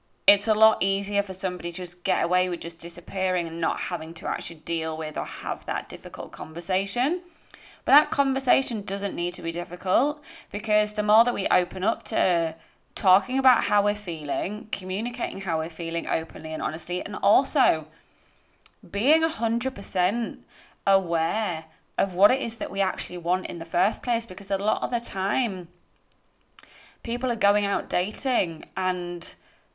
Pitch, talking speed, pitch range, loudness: 195 Hz, 170 wpm, 175-230 Hz, -25 LUFS